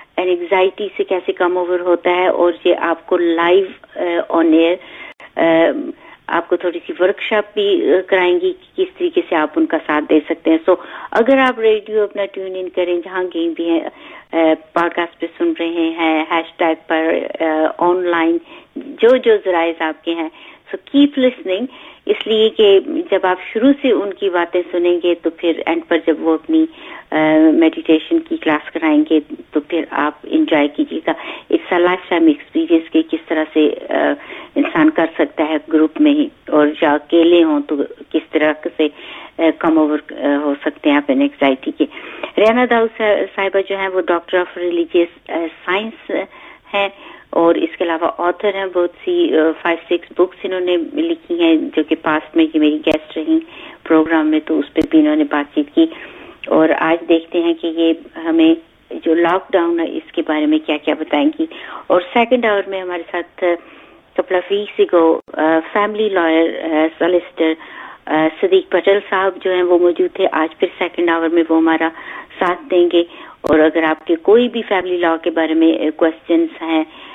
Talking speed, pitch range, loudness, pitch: 180 wpm, 160-230 Hz, -16 LUFS, 175 Hz